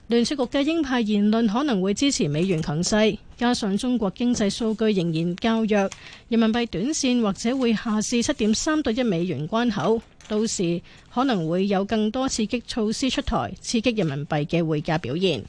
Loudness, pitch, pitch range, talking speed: -23 LUFS, 220 Hz, 190-240 Hz, 280 characters per minute